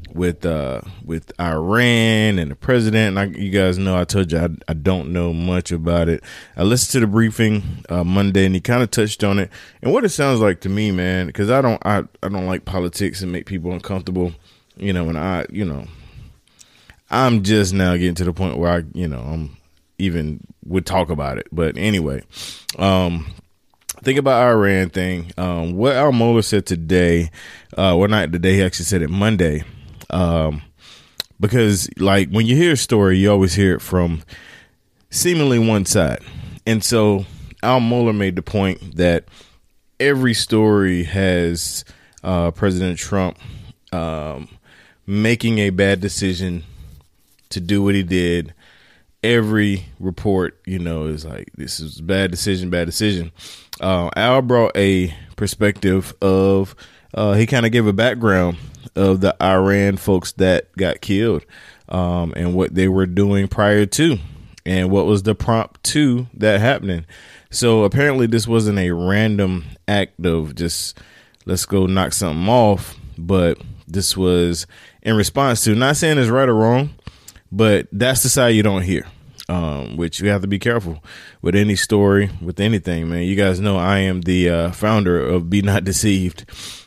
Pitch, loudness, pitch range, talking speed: 95 Hz, -18 LUFS, 85-105 Hz, 170 wpm